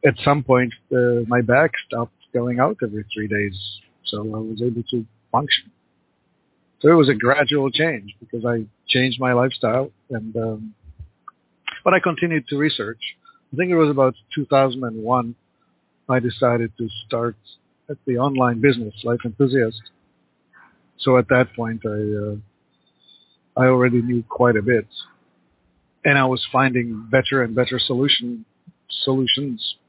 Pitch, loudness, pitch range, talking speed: 120 Hz, -20 LUFS, 110-135 Hz, 145 wpm